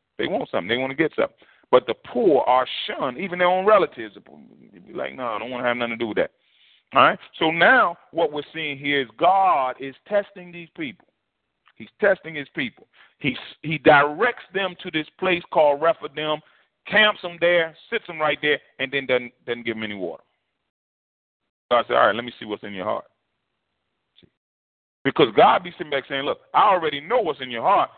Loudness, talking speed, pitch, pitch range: -21 LUFS, 210 wpm, 150 Hz, 125-175 Hz